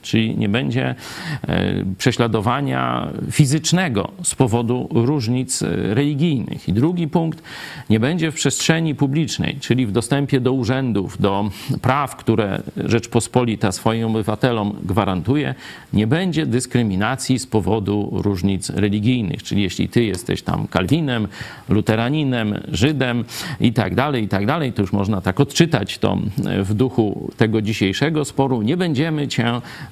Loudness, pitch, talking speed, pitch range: -19 LUFS, 120 Hz, 130 wpm, 105-140 Hz